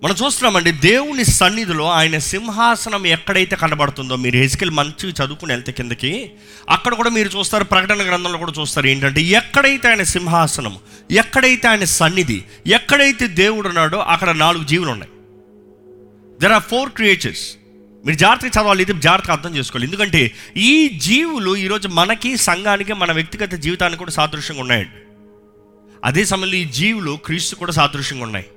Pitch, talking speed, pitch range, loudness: 175 Hz, 135 wpm, 140-205 Hz, -15 LUFS